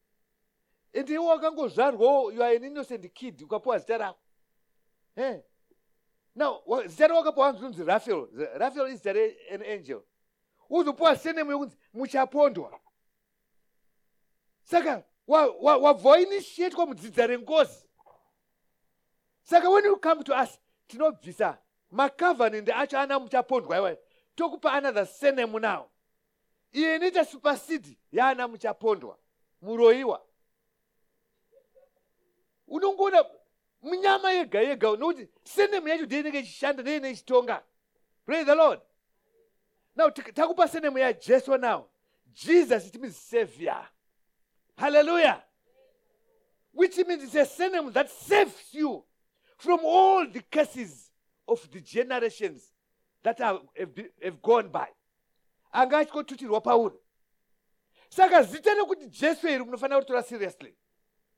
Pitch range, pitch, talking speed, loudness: 230-340 Hz, 280 Hz, 100 wpm, -26 LUFS